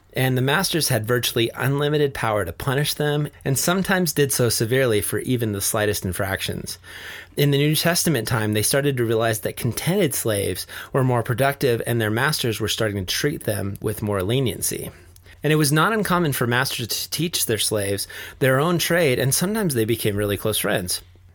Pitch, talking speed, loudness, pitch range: 125 Hz, 190 wpm, -21 LUFS, 105-145 Hz